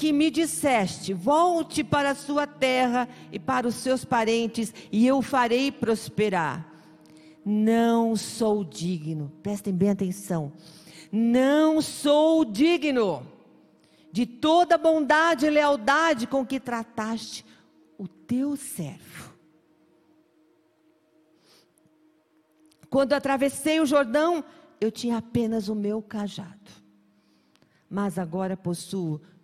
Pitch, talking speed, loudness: 225 Hz, 105 wpm, -25 LUFS